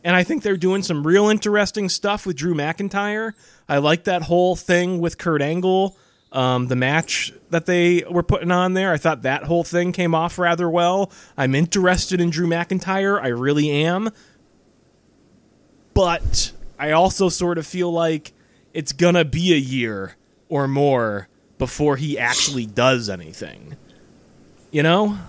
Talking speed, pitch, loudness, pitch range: 160 wpm, 170 Hz, -20 LUFS, 145-180 Hz